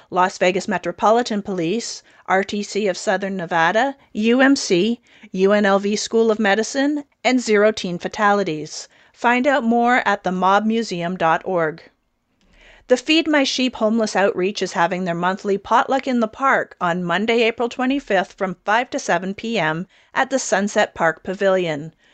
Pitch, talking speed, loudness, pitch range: 205 Hz, 140 wpm, -19 LUFS, 185-235 Hz